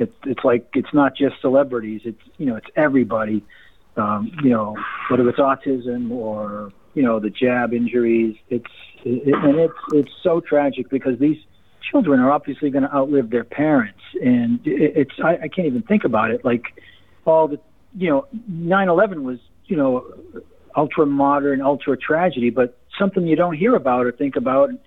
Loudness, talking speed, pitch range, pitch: -19 LUFS, 180 wpm, 120-165 Hz, 140 Hz